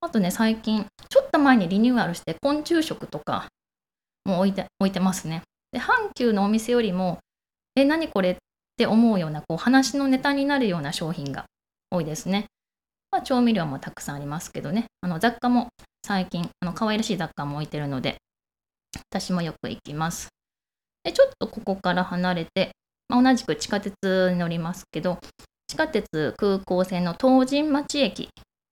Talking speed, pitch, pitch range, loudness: 330 characters per minute, 200 Hz, 175-245 Hz, -24 LUFS